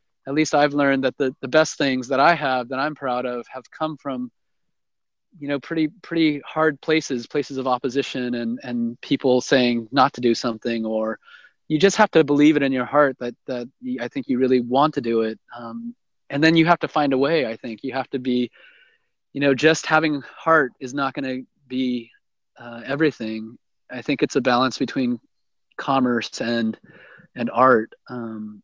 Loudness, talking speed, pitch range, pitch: -21 LUFS, 195 wpm, 120-150 Hz, 135 Hz